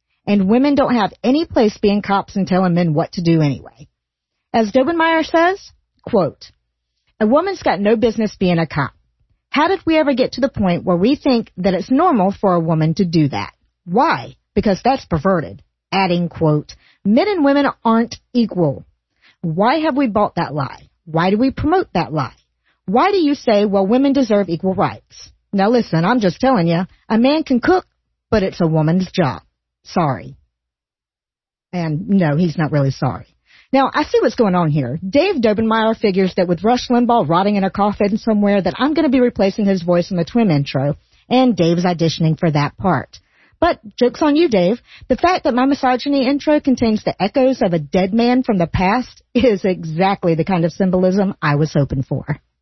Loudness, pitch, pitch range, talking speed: -16 LUFS, 200 Hz, 170-250 Hz, 195 wpm